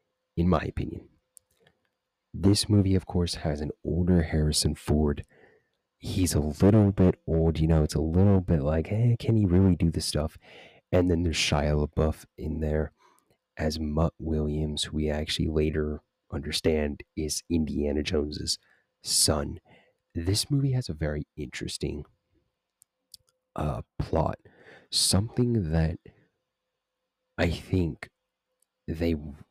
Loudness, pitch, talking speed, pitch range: -27 LUFS, 80 Hz, 130 wpm, 75-95 Hz